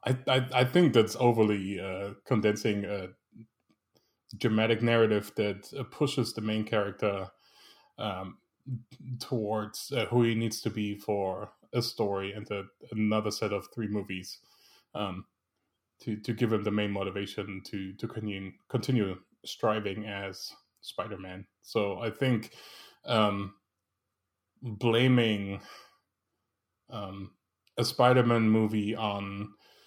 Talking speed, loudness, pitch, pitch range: 120 wpm, -30 LUFS, 105 Hz, 100-115 Hz